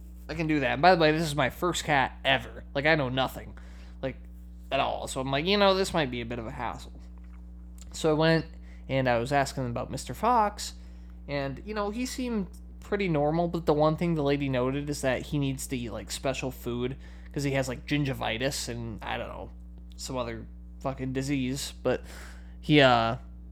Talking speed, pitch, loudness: 210 wpm, 130 Hz, -28 LUFS